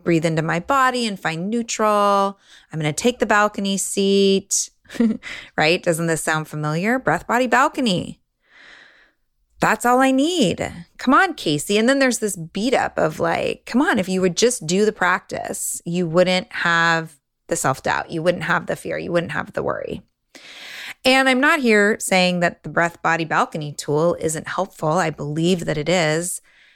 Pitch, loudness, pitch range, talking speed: 185 Hz, -19 LUFS, 165-235 Hz, 180 wpm